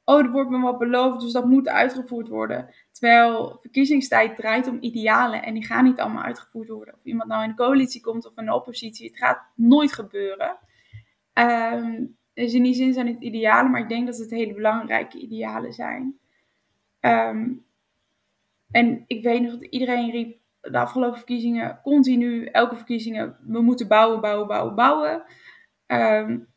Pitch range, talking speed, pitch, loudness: 225-255 Hz, 170 wpm, 240 Hz, -22 LUFS